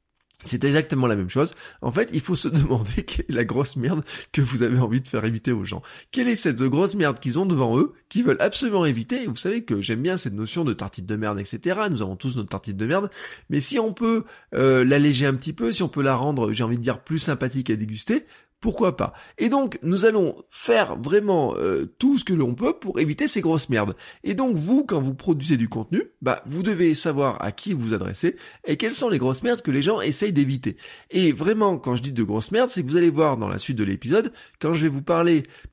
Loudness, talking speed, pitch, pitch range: -23 LUFS, 250 wpm, 145 Hz, 120-180 Hz